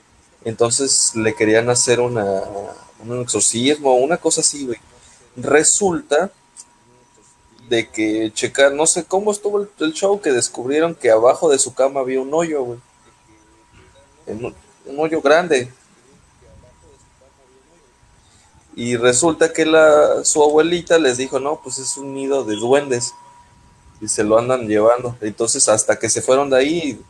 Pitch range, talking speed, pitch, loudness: 115-155 Hz, 145 wpm, 130 Hz, -16 LUFS